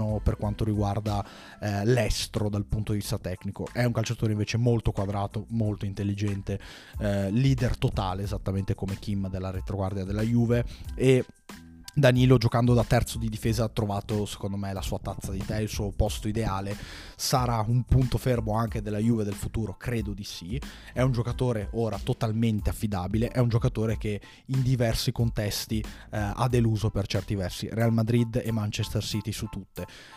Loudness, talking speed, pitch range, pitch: -28 LUFS, 170 wpm, 100-115 Hz, 110 Hz